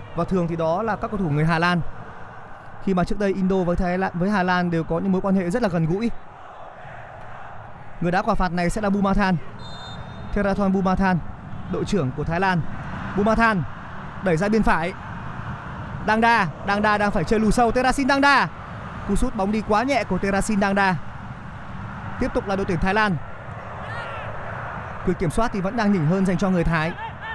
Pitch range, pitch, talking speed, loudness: 165-205 Hz, 190 Hz, 205 wpm, -22 LUFS